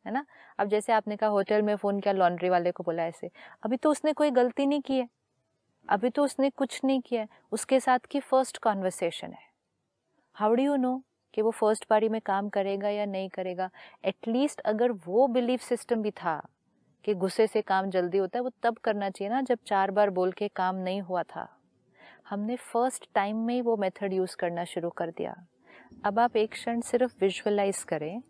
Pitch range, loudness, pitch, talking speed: 190-245 Hz, -28 LUFS, 215 Hz, 205 wpm